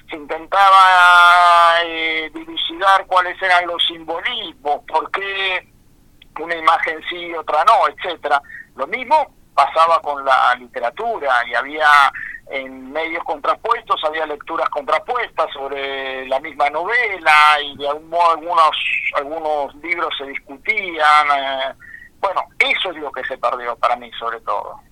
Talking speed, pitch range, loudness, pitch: 130 wpm, 145-180 Hz, -16 LUFS, 160 Hz